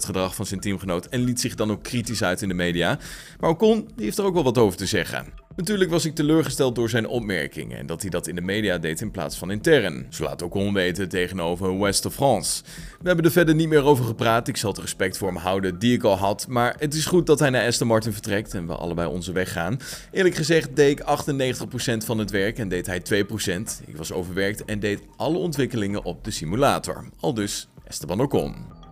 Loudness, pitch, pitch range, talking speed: -23 LUFS, 110 Hz, 95-140 Hz, 235 wpm